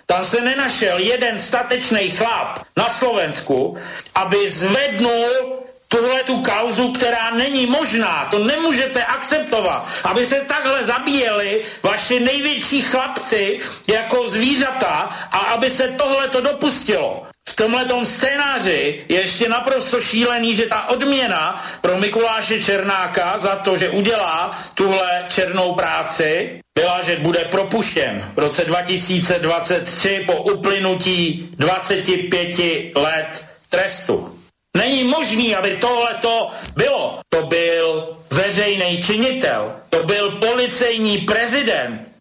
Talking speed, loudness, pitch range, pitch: 110 wpm, -17 LUFS, 185-250 Hz, 220 Hz